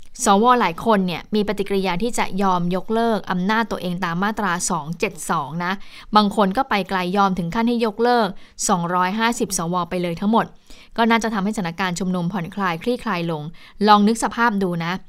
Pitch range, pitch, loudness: 180-225 Hz, 200 Hz, -20 LUFS